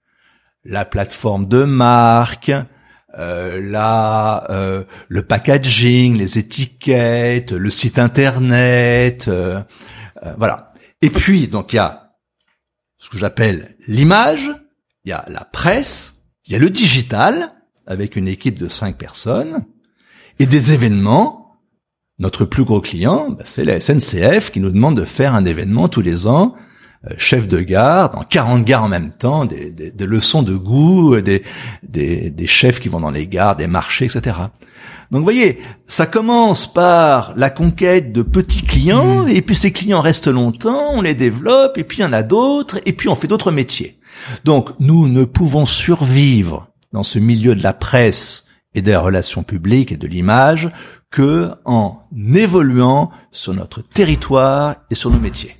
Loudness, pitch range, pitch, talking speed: -14 LUFS, 100-150 Hz, 120 Hz, 165 wpm